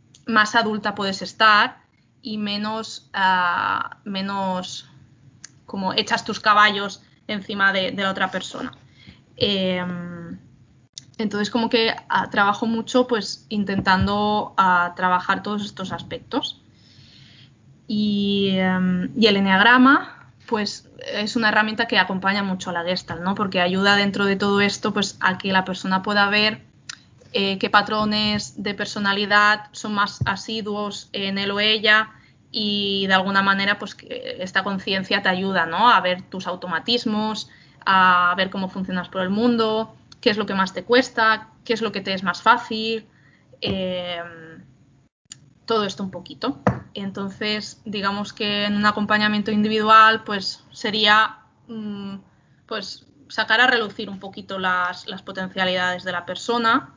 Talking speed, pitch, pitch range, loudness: 140 wpm, 205 Hz, 190-215 Hz, -20 LUFS